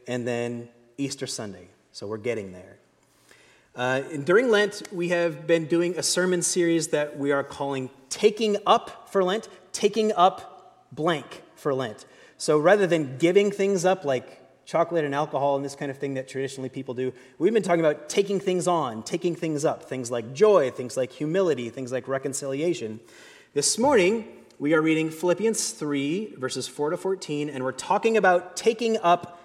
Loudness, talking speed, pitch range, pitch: -25 LUFS, 175 wpm, 130-180 Hz, 155 Hz